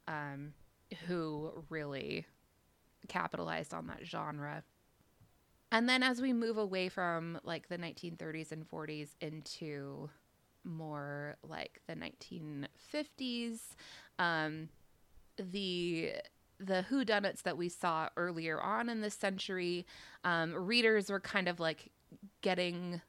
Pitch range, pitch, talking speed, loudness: 155-200 Hz, 175 Hz, 110 wpm, -38 LUFS